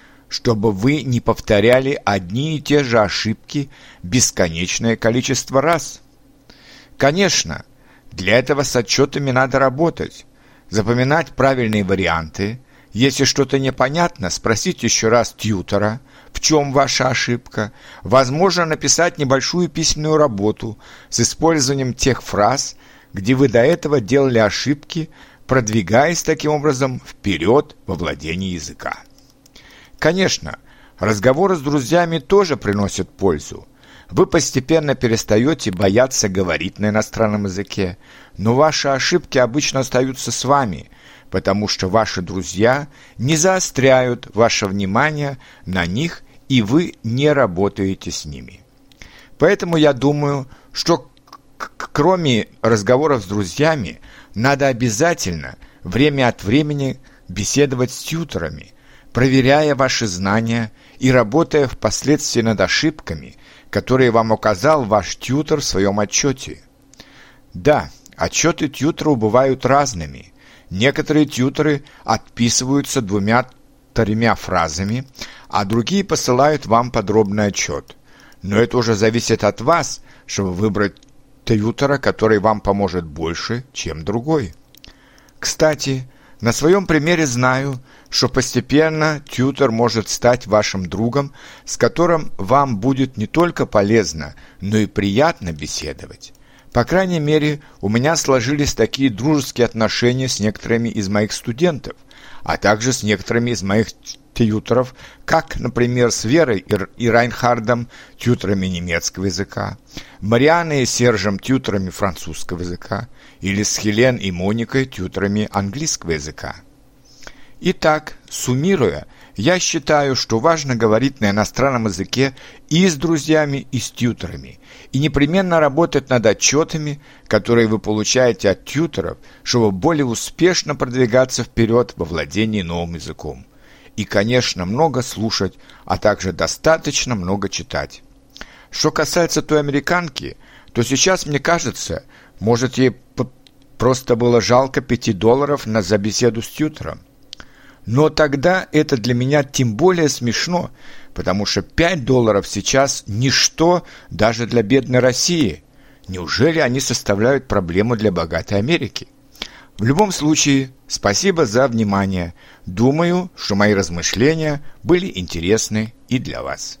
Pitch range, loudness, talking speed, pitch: 105-145 Hz, -17 LUFS, 120 wpm, 125 Hz